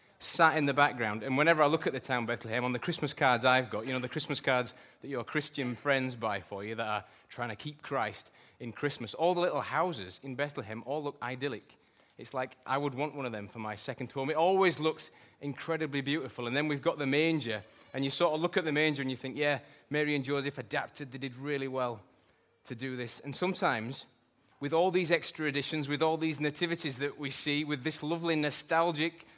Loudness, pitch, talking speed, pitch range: -32 LUFS, 145 Hz, 225 wpm, 130-155 Hz